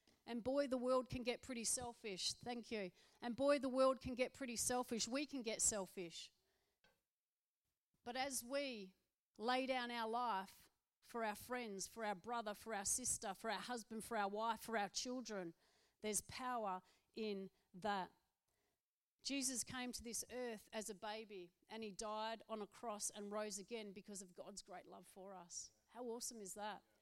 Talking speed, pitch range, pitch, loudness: 175 wpm, 205-245 Hz, 225 Hz, -45 LUFS